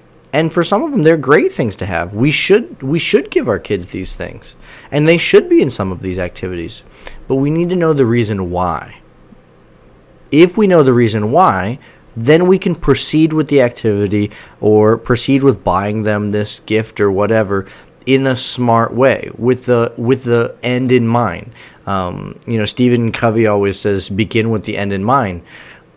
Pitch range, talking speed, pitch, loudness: 105-145 Hz, 190 wpm, 120 Hz, -14 LUFS